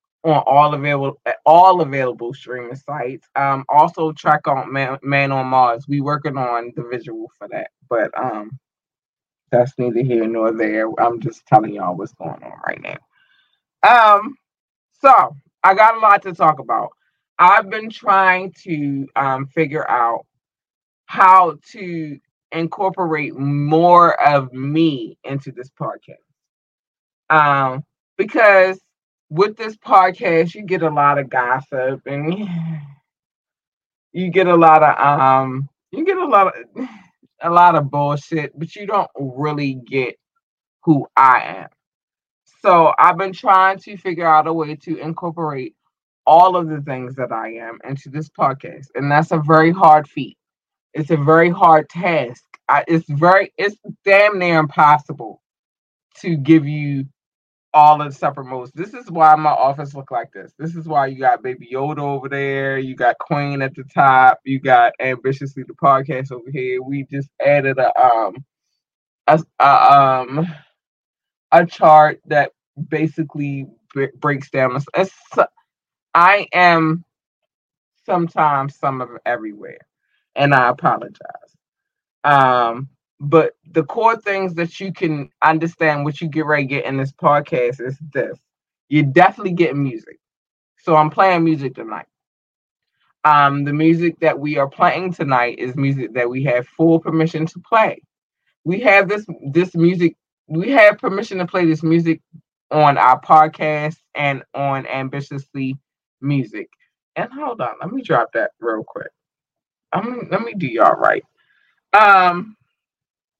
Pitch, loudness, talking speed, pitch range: 155 Hz, -16 LUFS, 150 wpm, 135-175 Hz